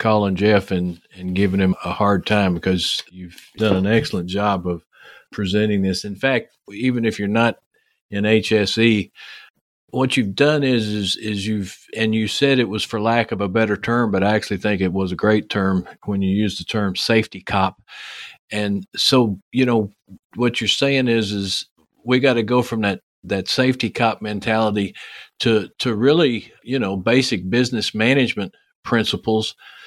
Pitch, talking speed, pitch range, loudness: 105 Hz, 175 wpm, 100-115 Hz, -19 LUFS